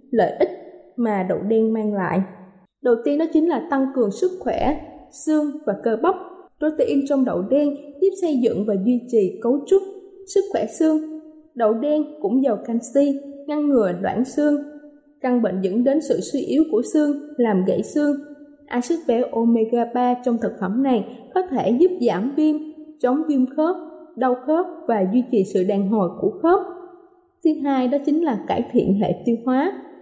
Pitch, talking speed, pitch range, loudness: 275 Hz, 180 wpm, 230-310 Hz, -21 LUFS